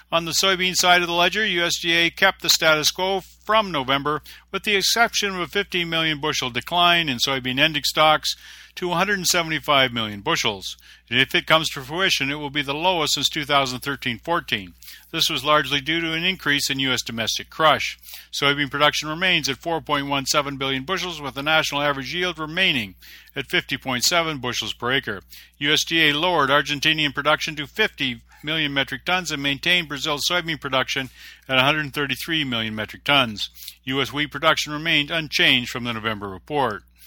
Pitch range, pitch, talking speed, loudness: 135-170 Hz, 150 Hz, 165 wpm, -20 LUFS